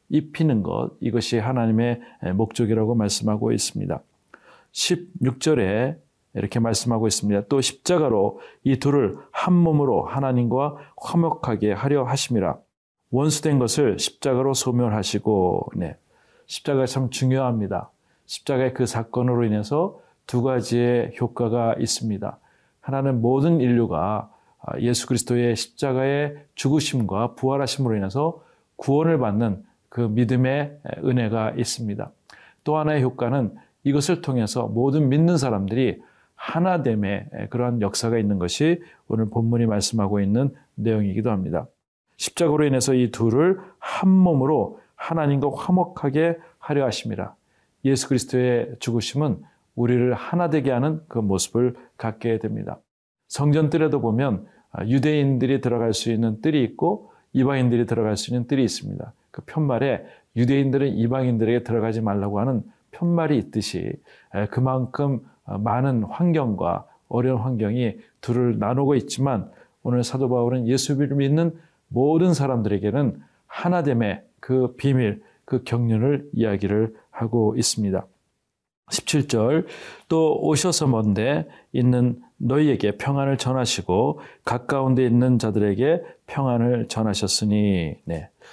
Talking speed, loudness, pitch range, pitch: 300 characters per minute, -22 LUFS, 115-140 Hz, 125 Hz